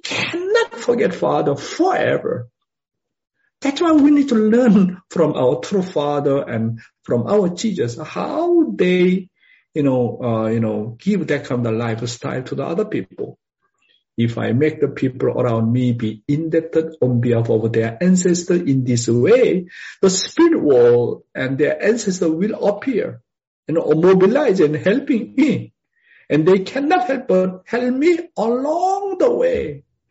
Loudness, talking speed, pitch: -18 LUFS, 150 wpm, 185 Hz